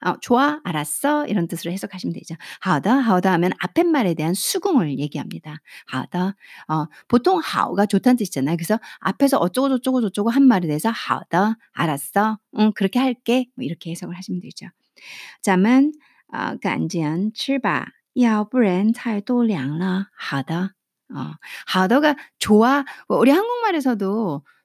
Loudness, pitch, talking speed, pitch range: -20 LUFS, 210 Hz, 315 characters per minute, 175-255 Hz